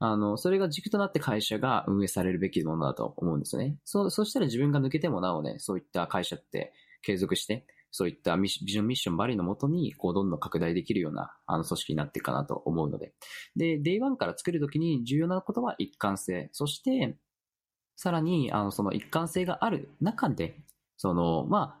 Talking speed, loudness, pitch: 420 characters per minute, -30 LUFS, 130 Hz